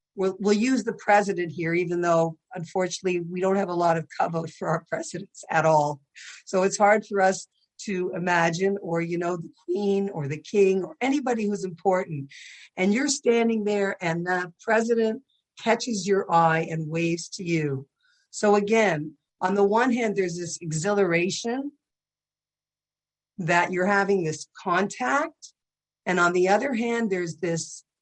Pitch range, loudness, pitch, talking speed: 170-210 Hz, -25 LUFS, 190 Hz, 160 wpm